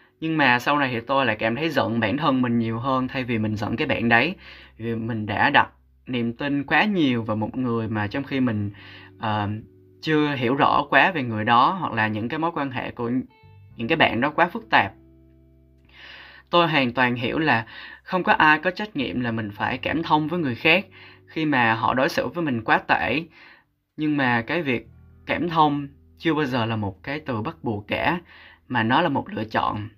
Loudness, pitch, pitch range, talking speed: -22 LUFS, 120 Hz, 105-145 Hz, 220 wpm